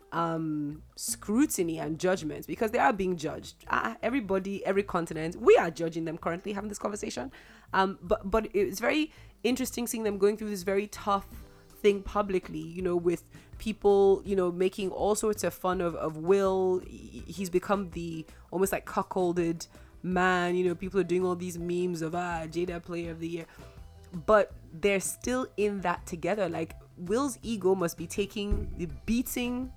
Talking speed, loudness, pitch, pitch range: 175 wpm, -30 LUFS, 185 Hz, 170-205 Hz